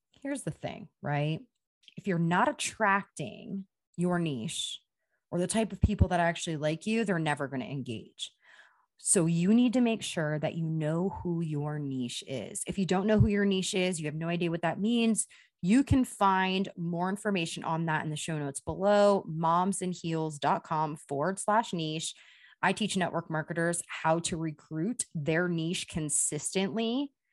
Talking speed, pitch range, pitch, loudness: 170 wpm, 160-195 Hz, 175 Hz, -30 LUFS